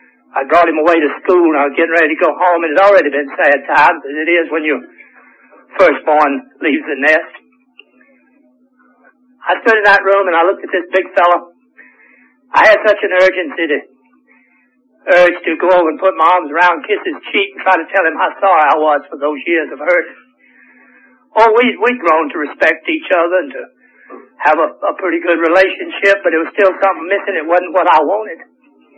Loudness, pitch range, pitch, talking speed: -12 LUFS, 165-250 Hz, 185 Hz, 205 wpm